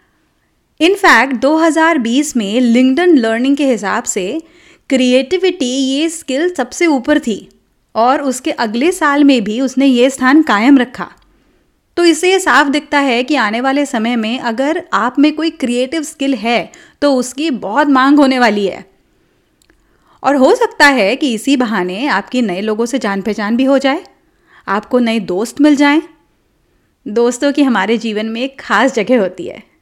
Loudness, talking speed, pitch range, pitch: -13 LUFS, 165 wpm, 235-295 Hz, 265 Hz